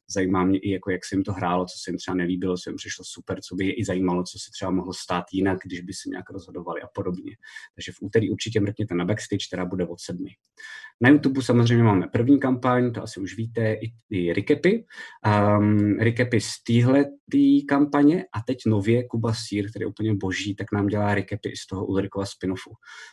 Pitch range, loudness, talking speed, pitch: 95-120 Hz, -24 LUFS, 215 wpm, 105 Hz